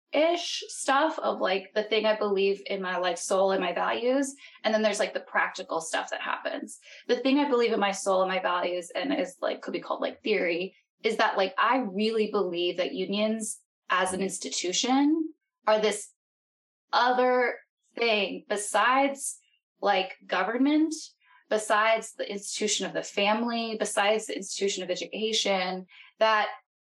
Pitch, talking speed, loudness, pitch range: 215 Hz, 160 wpm, -27 LUFS, 195-260 Hz